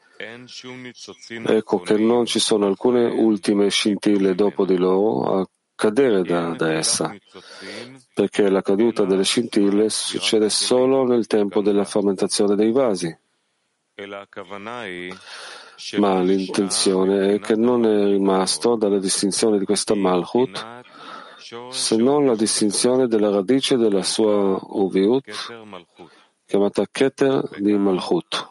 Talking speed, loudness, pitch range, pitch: 115 wpm, -19 LUFS, 100-120 Hz, 105 Hz